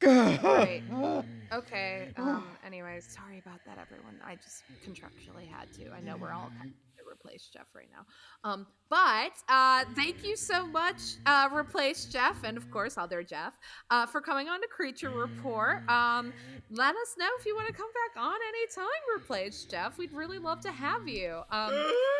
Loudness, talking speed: -30 LUFS, 180 wpm